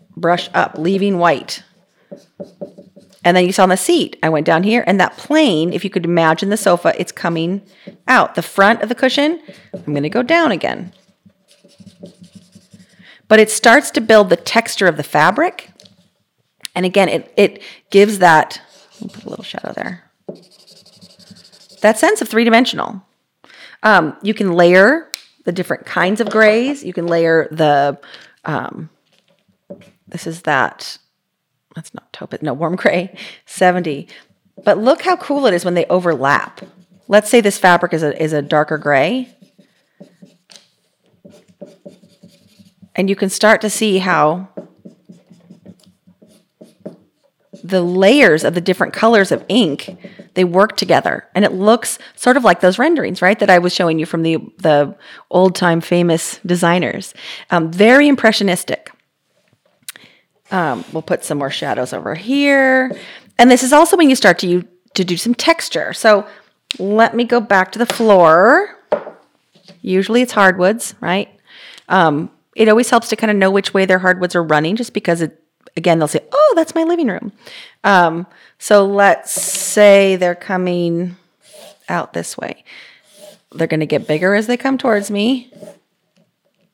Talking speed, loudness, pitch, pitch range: 155 wpm, -14 LUFS, 195 Hz, 180-220 Hz